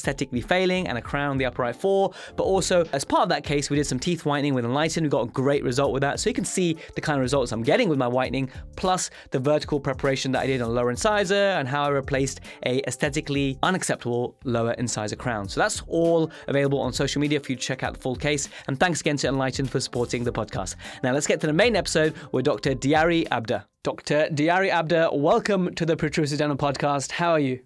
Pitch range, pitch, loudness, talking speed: 130-160 Hz, 145 Hz, -24 LUFS, 240 wpm